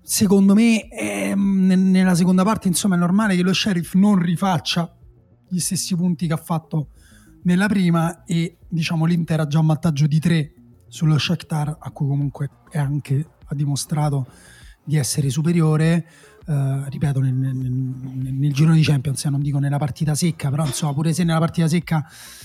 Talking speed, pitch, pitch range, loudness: 175 wpm, 160 Hz, 140-175 Hz, -20 LUFS